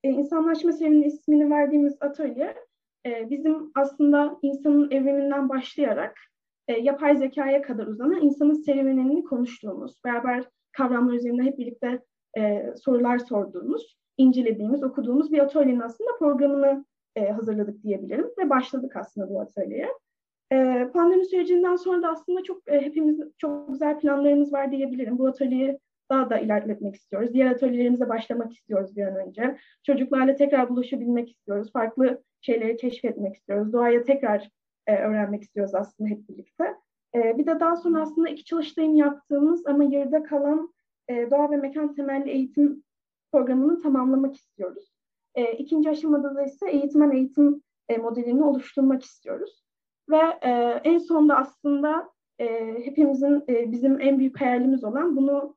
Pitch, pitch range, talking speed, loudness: 275 Hz, 245-295 Hz, 125 wpm, -24 LUFS